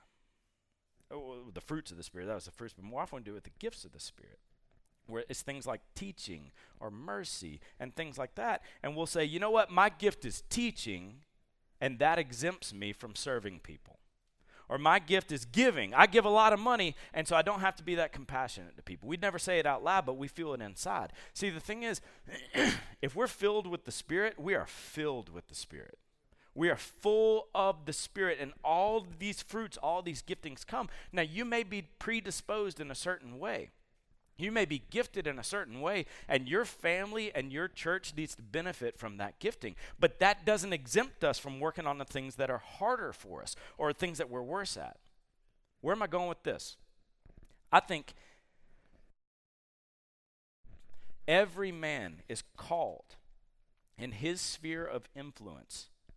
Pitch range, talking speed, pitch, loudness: 120-195 Hz, 190 wpm, 160 Hz, -34 LUFS